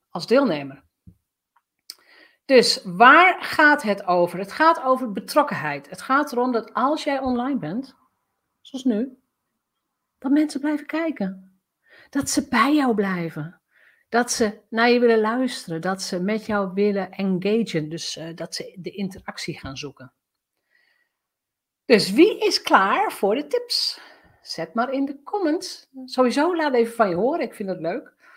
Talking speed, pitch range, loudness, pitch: 150 wpm, 190-280 Hz, -21 LUFS, 235 Hz